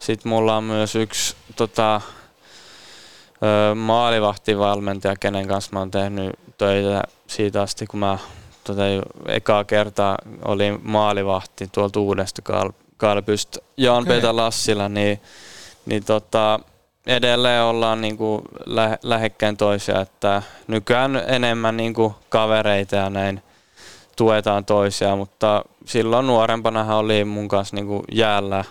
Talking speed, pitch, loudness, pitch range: 115 wpm, 105 Hz, -20 LUFS, 100-110 Hz